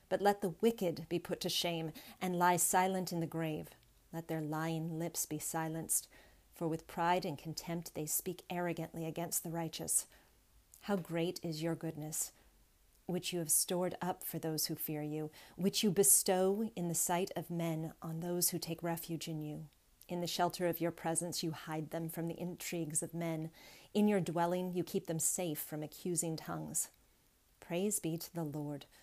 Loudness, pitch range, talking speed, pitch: -36 LUFS, 160-175 Hz, 185 wpm, 170 Hz